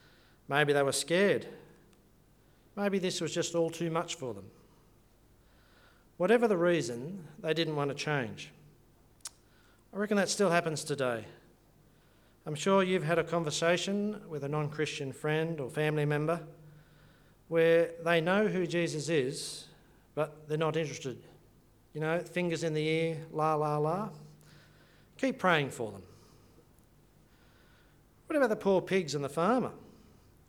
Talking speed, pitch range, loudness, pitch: 140 wpm, 145-175 Hz, -31 LUFS, 160 Hz